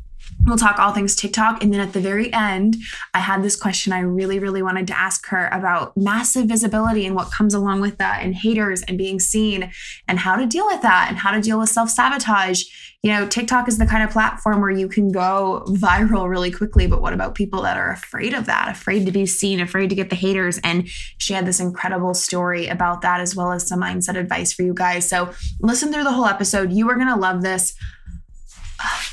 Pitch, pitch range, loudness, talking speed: 195 Hz, 180-210 Hz, -19 LUFS, 230 wpm